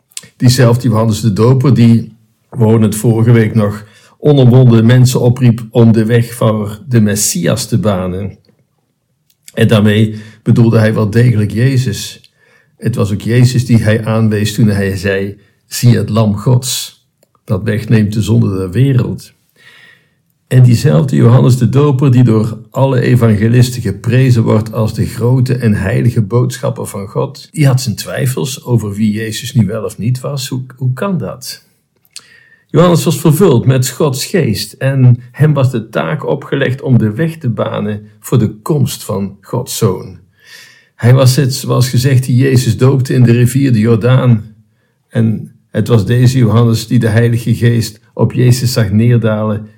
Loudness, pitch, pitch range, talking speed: -11 LUFS, 120 Hz, 110-130 Hz, 160 wpm